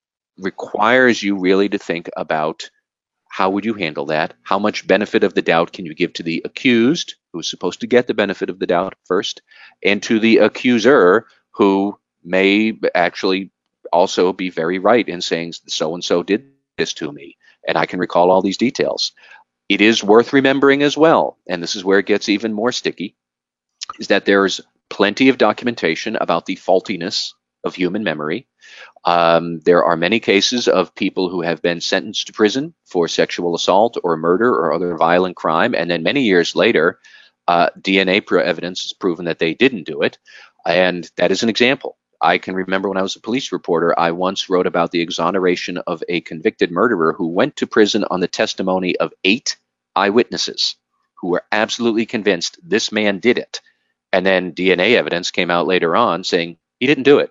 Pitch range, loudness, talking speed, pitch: 85-110 Hz, -17 LUFS, 190 wpm, 95 Hz